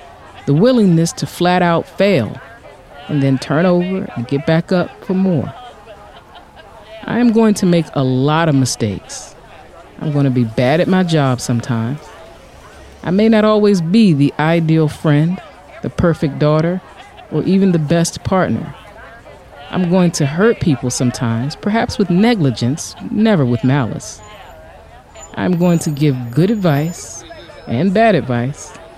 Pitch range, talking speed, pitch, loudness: 140-185 Hz, 145 wpm, 165 Hz, -15 LUFS